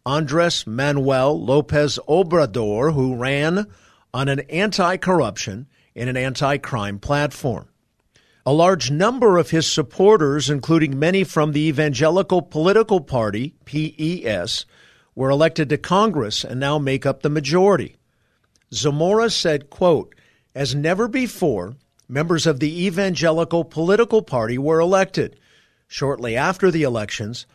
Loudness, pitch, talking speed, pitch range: -19 LUFS, 150 Hz, 120 wpm, 130-170 Hz